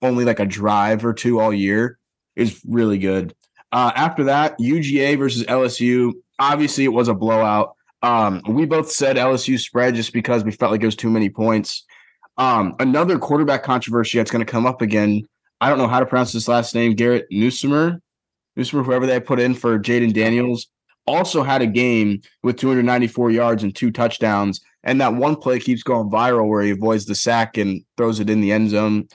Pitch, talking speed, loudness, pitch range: 120 Hz, 195 wpm, -18 LUFS, 110-125 Hz